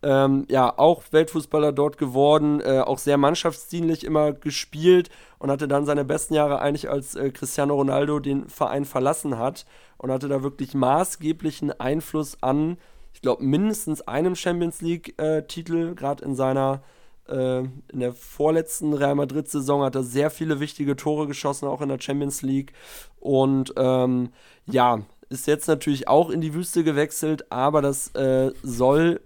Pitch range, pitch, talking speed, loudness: 135-155 Hz, 145 Hz, 160 wpm, -23 LUFS